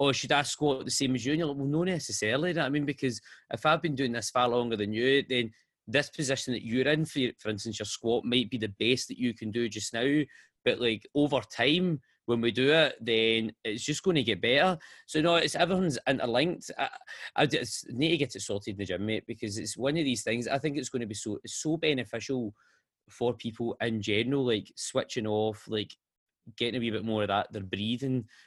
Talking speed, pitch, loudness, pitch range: 230 wpm, 120 Hz, -29 LUFS, 110-145 Hz